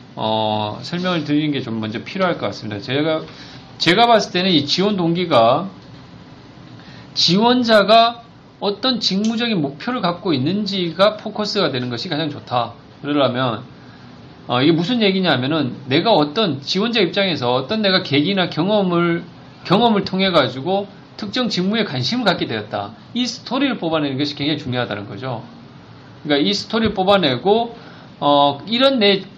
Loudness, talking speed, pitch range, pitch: -18 LUFS, 325 characters per minute, 140-205 Hz, 170 Hz